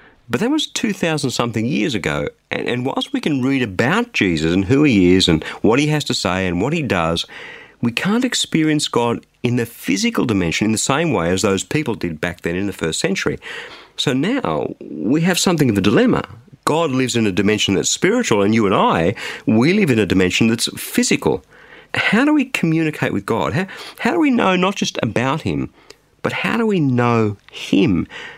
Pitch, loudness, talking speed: 130 Hz, -18 LUFS, 205 wpm